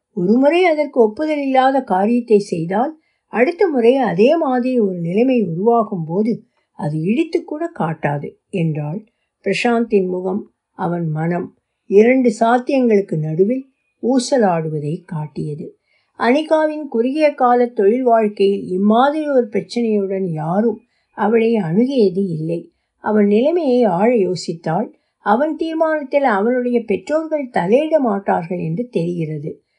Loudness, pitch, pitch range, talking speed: -17 LUFS, 225 Hz, 190-260 Hz, 105 wpm